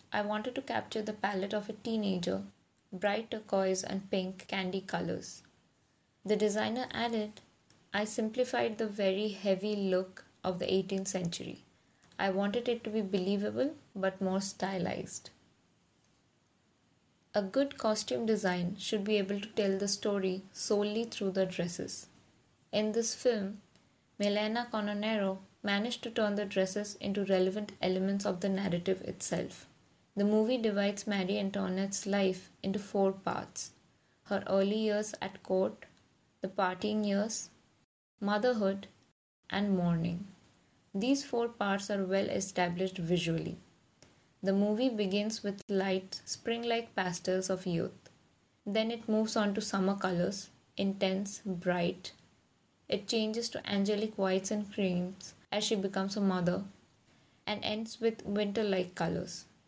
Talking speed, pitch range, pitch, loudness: 135 wpm, 190-215 Hz, 200 Hz, -34 LUFS